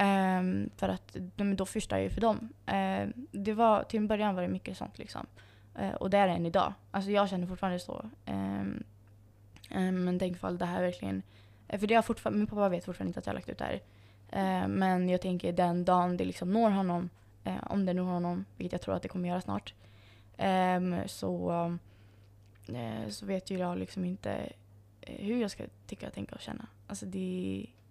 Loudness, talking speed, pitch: -33 LUFS, 210 wpm, 175 Hz